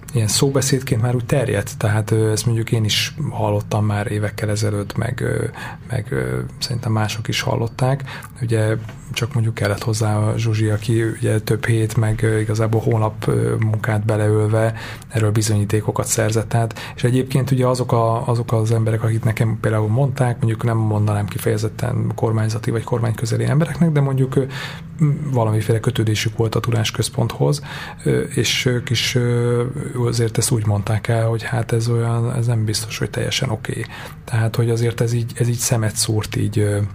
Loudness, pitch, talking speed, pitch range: -19 LUFS, 115 Hz, 155 wpm, 110-125 Hz